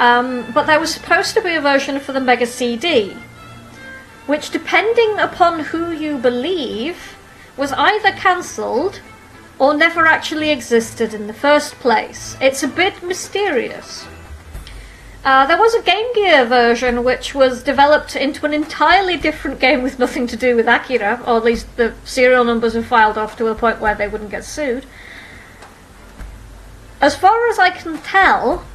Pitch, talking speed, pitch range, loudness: 275 Hz, 165 wpm, 235-330 Hz, -15 LUFS